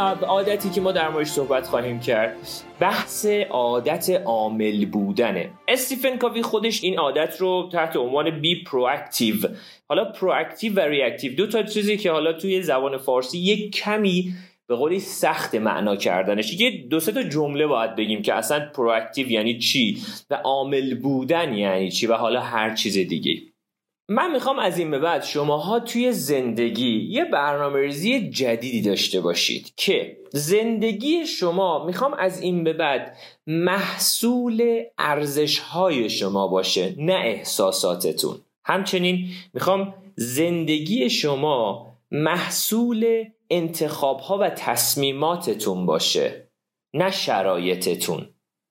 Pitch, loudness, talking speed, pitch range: 165 Hz, -22 LUFS, 130 wpm, 130-200 Hz